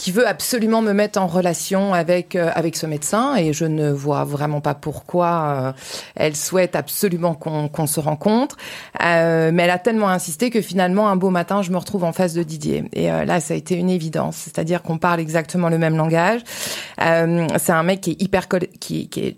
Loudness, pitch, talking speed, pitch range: -19 LUFS, 175 Hz, 215 wpm, 160-190 Hz